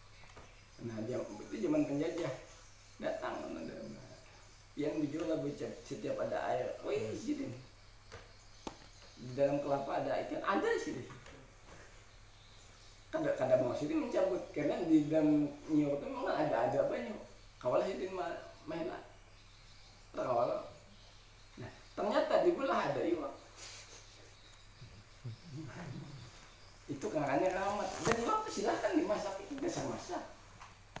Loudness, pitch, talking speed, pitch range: -36 LUFS, 130 Hz, 120 wpm, 105-175 Hz